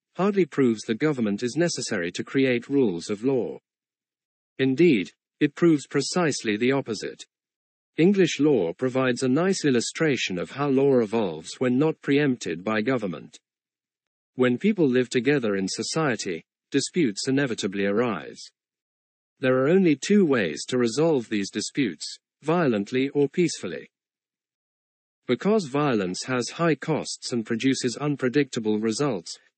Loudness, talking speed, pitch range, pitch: -24 LUFS, 125 wpm, 115-150 Hz, 130 Hz